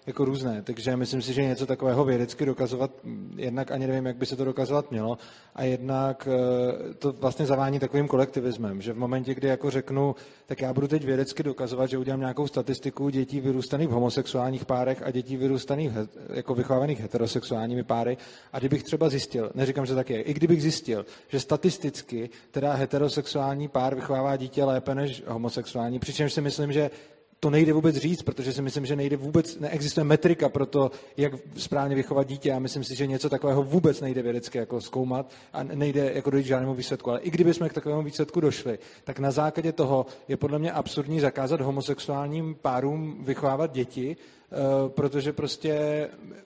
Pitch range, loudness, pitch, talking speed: 130-145 Hz, -27 LUFS, 135 Hz, 175 wpm